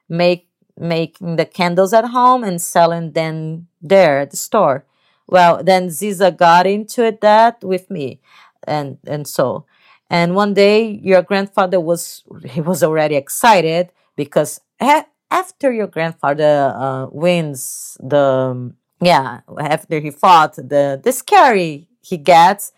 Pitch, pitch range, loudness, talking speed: 175 Hz, 150-195 Hz, -15 LUFS, 135 wpm